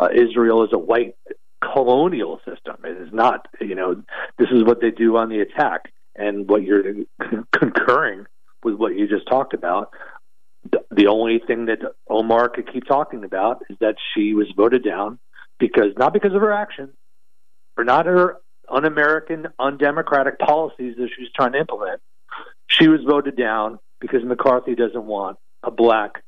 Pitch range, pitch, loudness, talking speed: 105-145 Hz, 120 Hz, -19 LUFS, 170 wpm